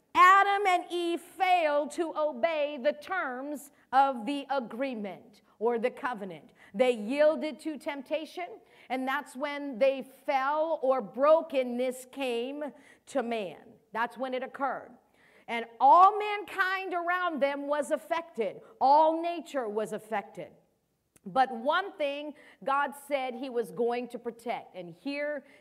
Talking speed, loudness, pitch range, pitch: 130 wpm, -29 LUFS, 245-315 Hz, 280 Hz